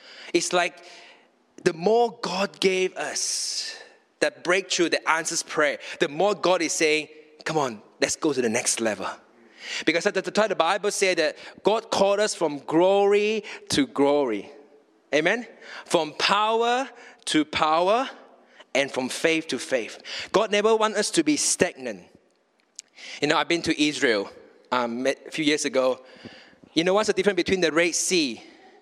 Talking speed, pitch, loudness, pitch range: 160 wpm, 185 Hz, -24 LUFS, 155-220 Hz